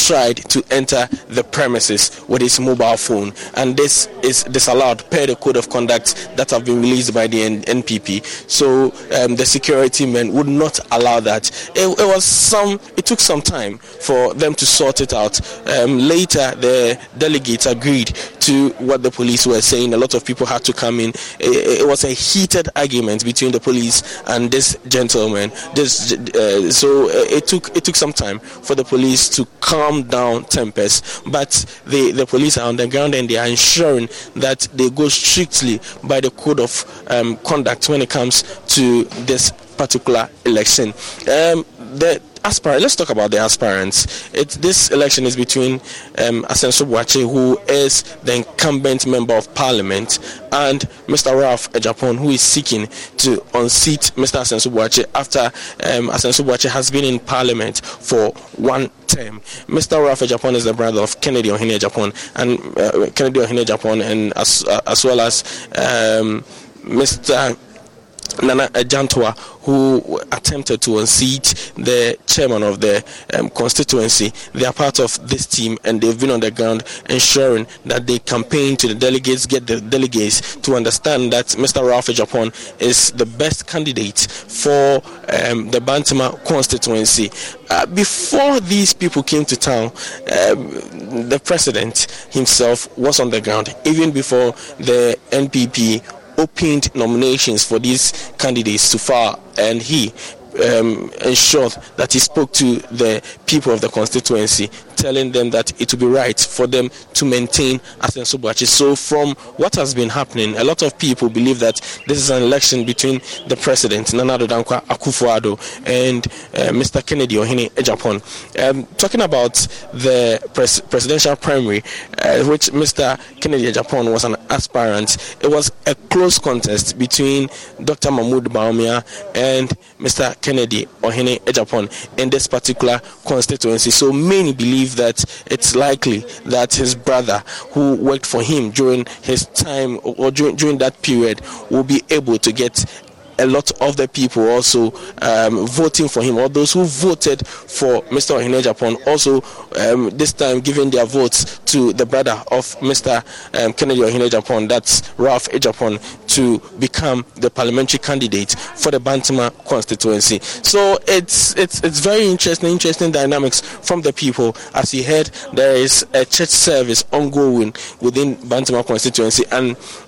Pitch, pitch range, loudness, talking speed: 125 Hz, 115-140 Hz, -15 LUFS, 155 wpm